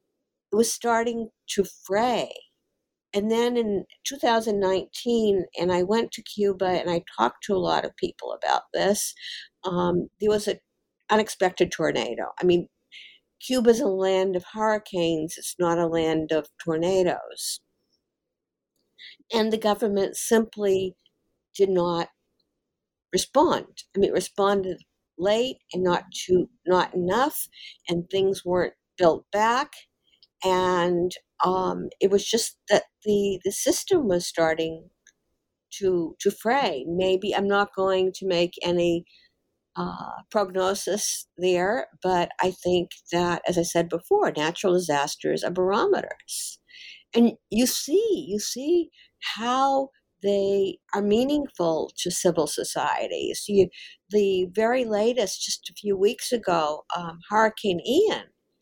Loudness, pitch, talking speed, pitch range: -25 LUFS, 195 Hz, 130 wpm, 175-225 Hz